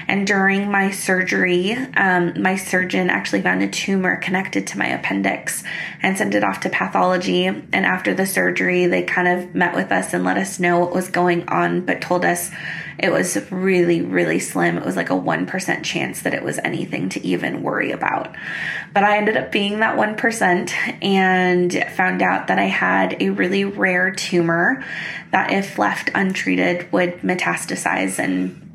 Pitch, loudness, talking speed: 180 Hz, -19 LUFS, 175 wpm